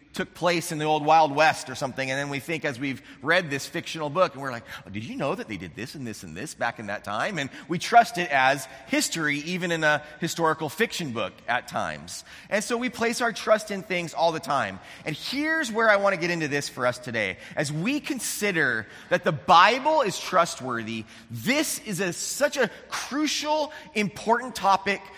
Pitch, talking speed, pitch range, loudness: 170 Hz, 215 wpm, 145-215 Hz, -25 LUFS